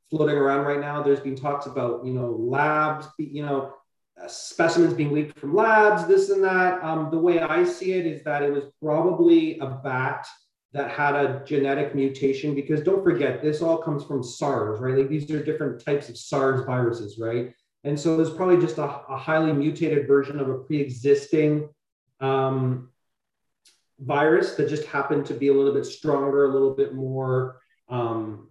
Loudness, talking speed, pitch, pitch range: -23 LUFS, 185 wpm, 145 Hz, 135-155 Hz